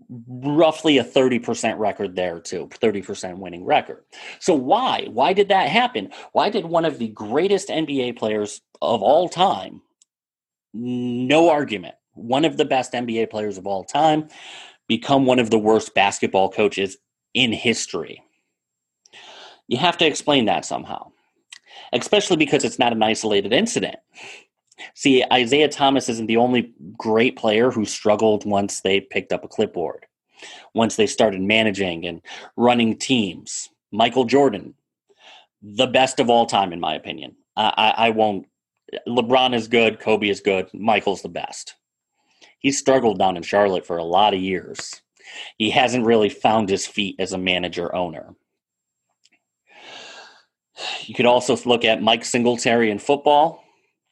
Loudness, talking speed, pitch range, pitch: -20 LUFS, 150 wpm, 100-135 Hz, 115 Hz